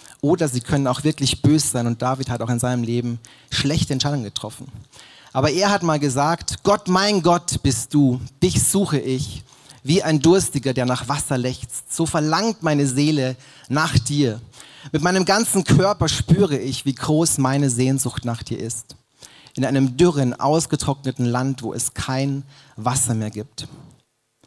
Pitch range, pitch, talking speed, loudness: 125-155 Hz, 135 Hz, 165 wpm, -20 LUFS